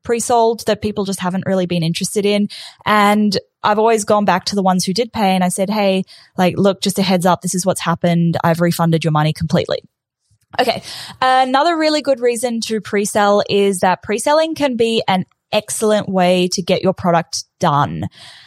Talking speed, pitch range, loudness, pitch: 190 wpm, 180-225 Hz, -16 LUFS, 200 Hz